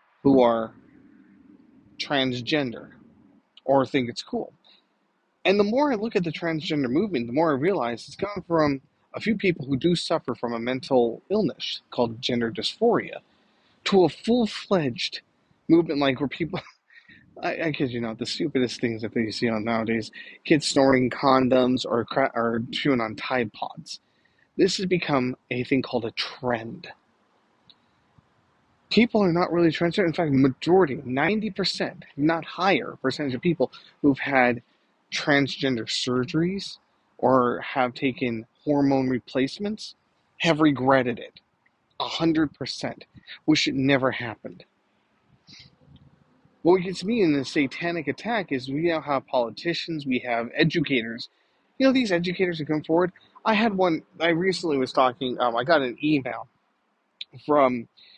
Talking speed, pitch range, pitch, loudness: 145 wpm, 125-170 Hz, 140 Hz, -24 LUFS